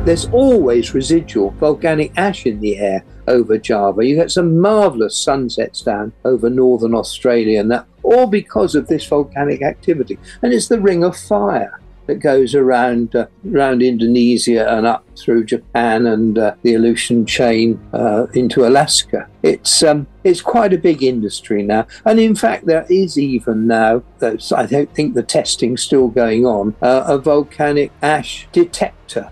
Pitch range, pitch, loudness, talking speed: 115-155 Hz, 125 Hz, -14 LUFS, 160 wpm